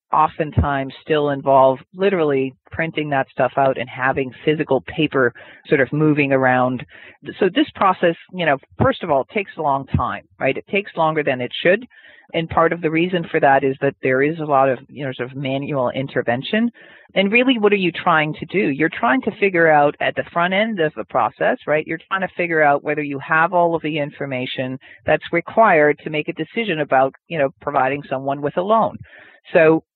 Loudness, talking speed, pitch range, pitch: -19 LUFS, 210 wpm, 135-170 Hz, 150 Hz